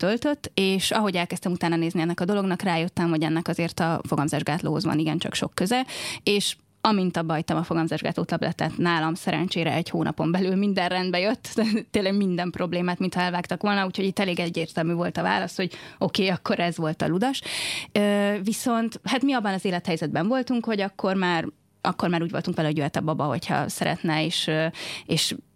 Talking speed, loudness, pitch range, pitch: 190 wpm, -25 LUFS, 165-200 Hz, 180 Hz